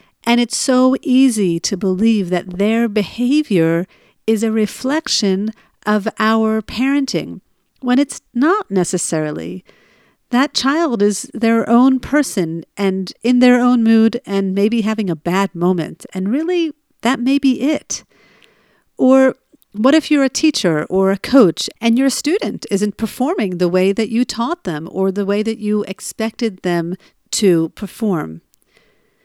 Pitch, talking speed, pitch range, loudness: 220 Hz, 145 wpm, 195-255 Hz, -16 LUFS